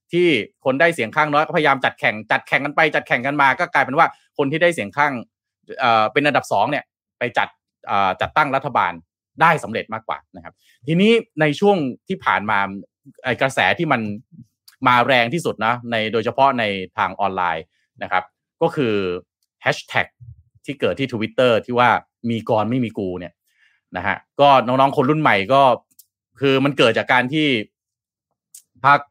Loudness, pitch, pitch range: -18 LUFS, 130 Hz, 110-150 Hz